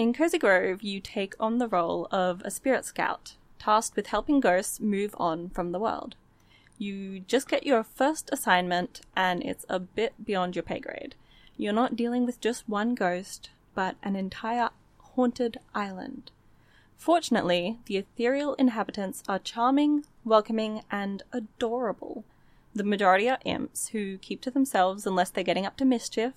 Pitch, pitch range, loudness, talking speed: 215 Hz, 190-245 Hz, -28 LUFS, 160 wpm